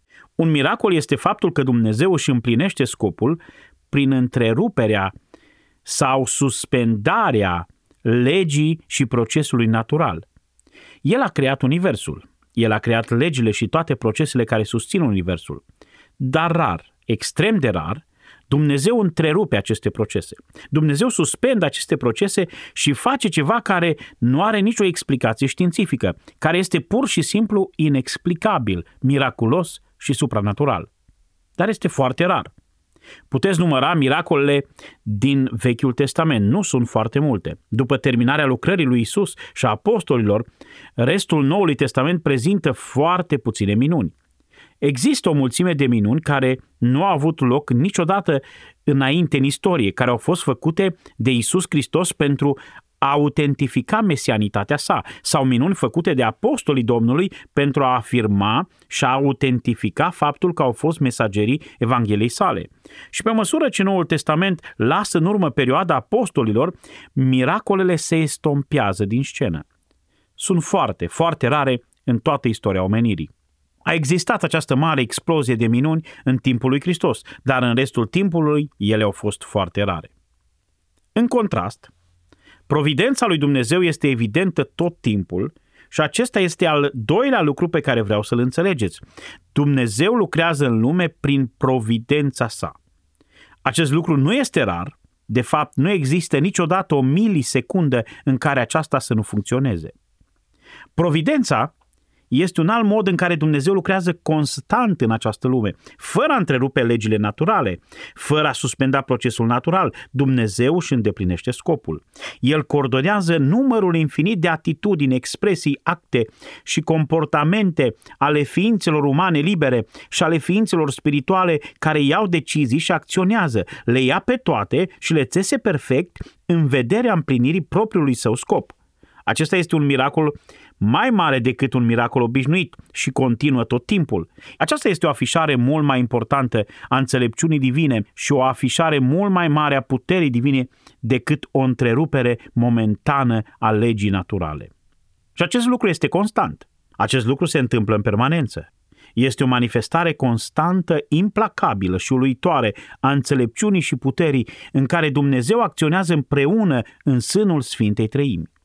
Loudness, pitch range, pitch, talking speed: -19 LUFS, 120-170 Hz, 140 Hz, 135 wpm